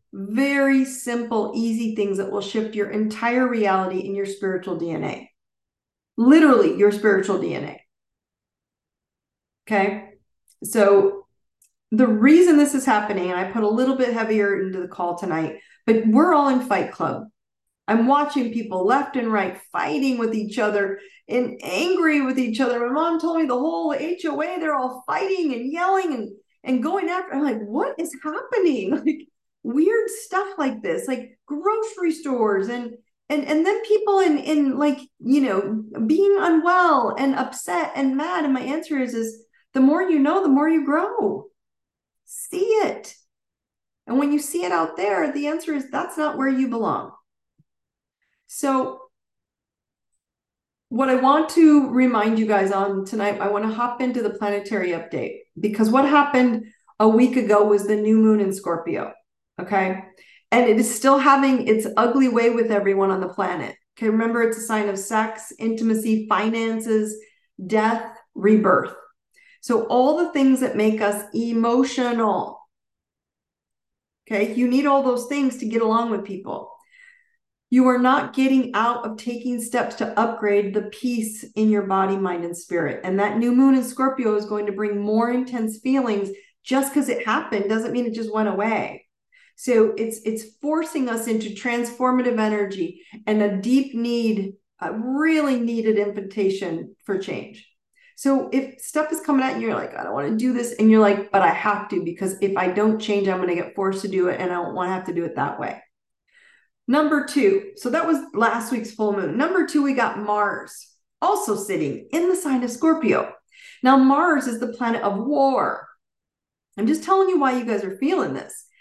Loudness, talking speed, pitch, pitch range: -21 LUFS, 175 wpm, 235 Hz, 210-285 Hz